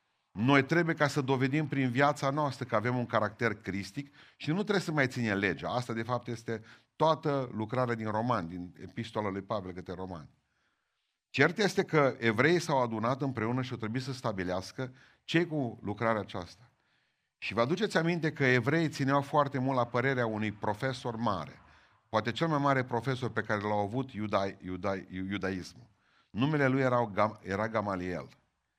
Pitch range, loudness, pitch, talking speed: 105-140 Hz, -31 LUFS, 120 Hz, 170 wpm